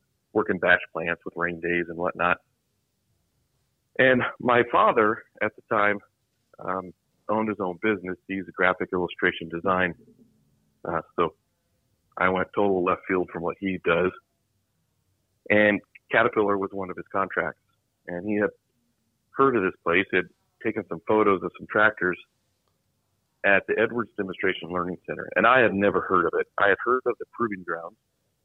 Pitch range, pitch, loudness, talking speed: 90-110 Hz, 95 Hz, -25 LUFS, 160 wpm